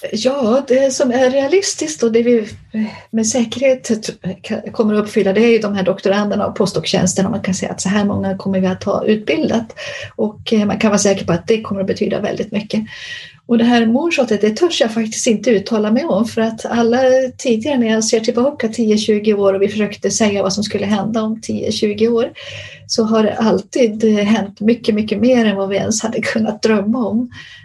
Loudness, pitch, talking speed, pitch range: -16 LUFS, 220 Hz, 205 wpm, 205-240 Hz